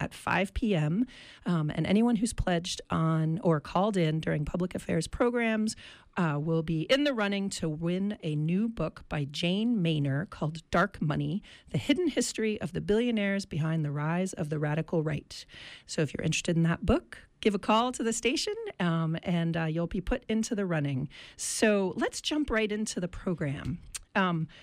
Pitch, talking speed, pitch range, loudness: 180 Hz, 185 wpm, 160-220 Hz, -30 LUFS